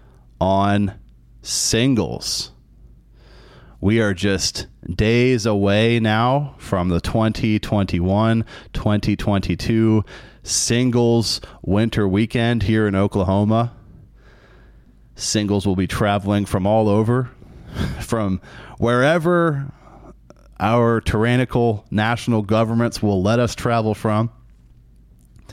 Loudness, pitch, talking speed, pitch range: -19 LUFS, 110 Hz, 85 wpm, 100-115 Hz